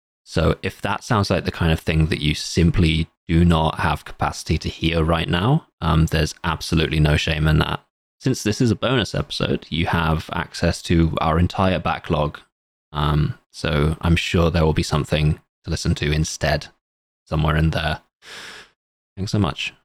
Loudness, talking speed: -21 LUFS, 175 wpm